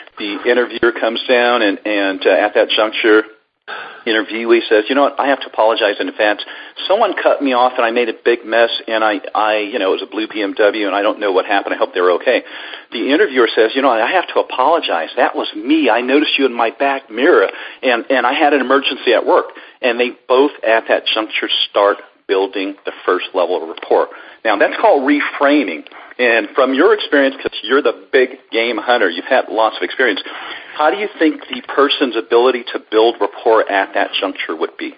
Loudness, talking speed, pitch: -15 LUFS, 215 wpm, 125 Hz